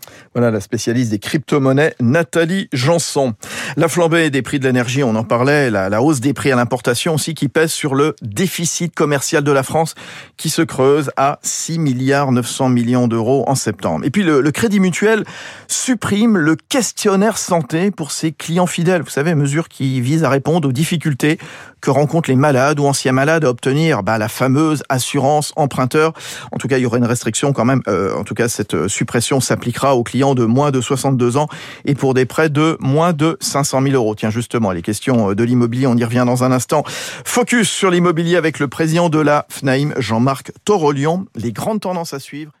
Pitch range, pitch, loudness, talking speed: 130-165 Hz, 145 Hz, -16 LUFS, 200 wpm